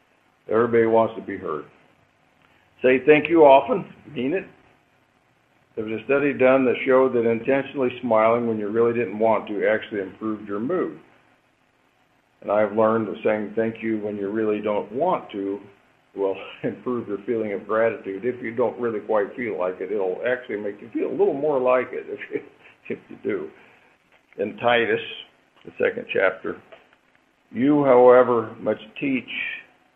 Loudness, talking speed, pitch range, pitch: -22 LUFS, 165 wpm, 105-140 Hz, 115 Hz